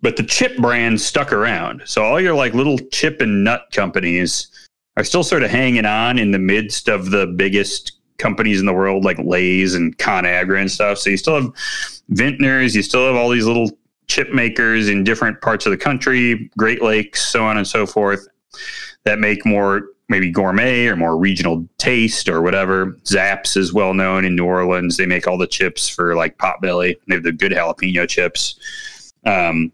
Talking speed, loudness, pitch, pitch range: 195 wpm, -16 LUFS, 100 Hz, 90-115 Hz